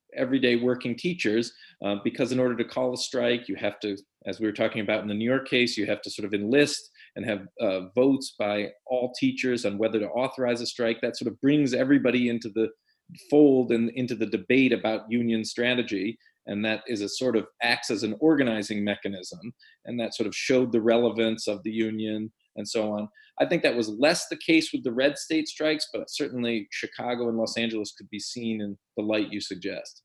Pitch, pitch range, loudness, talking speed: 115 Hz, 105-125 Hz, -26 LUFS, 215 wpm